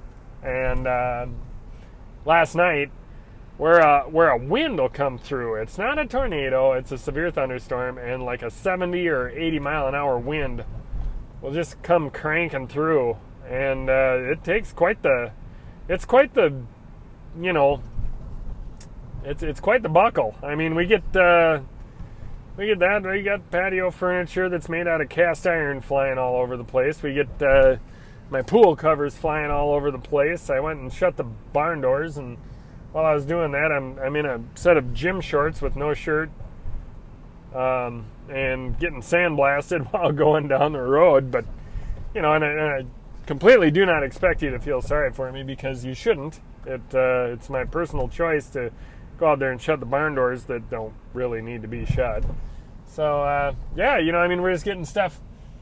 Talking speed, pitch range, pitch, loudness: 185 wpm, 125-160 Hz, 140 Hz, -22 LUFS